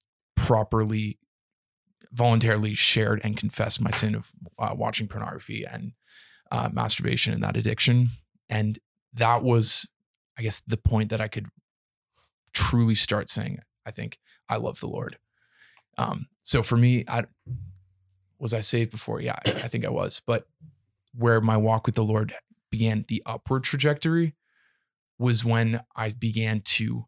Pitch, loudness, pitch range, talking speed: 110 Hz, -25 LUFS, 110-120 Hz, 145 wpm